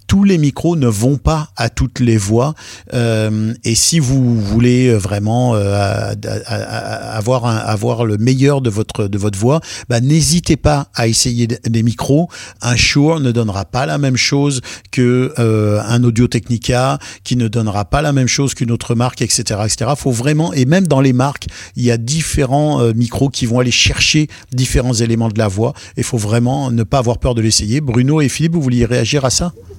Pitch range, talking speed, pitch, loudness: 115-135 Hz, 200 wpm, 120 Hz, -14 LUFS